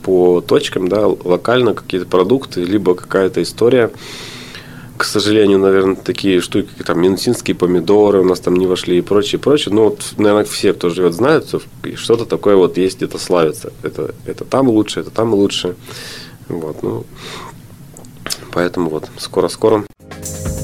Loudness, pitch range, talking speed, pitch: -15 LUFS, 90-105 Hz, 150 wpm, 95 Hz